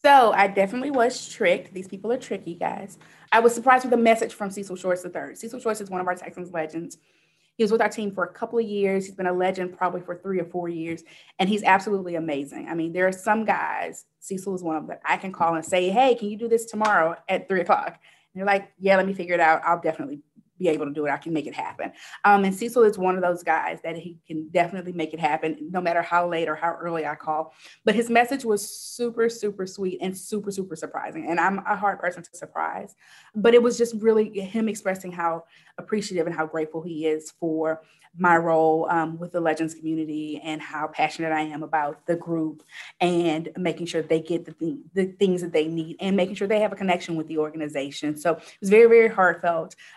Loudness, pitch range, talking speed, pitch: -24 LUFS, 160-200 Hz, 240 wpm, 180 Hz